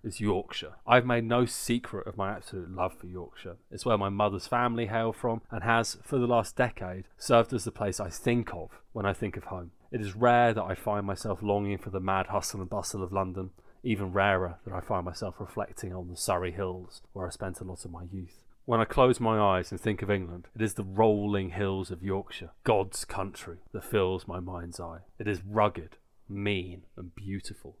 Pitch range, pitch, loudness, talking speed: 90-110 Hz, 100 Hz, -30 LUFS, 220 wpm